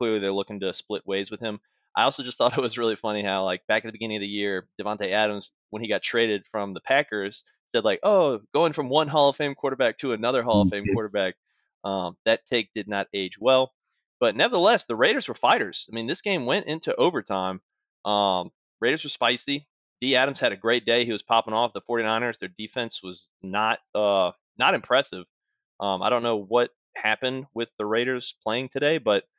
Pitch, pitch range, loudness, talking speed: 110 Hz, 100-125 Hz, -25 LUFS, 215 wpm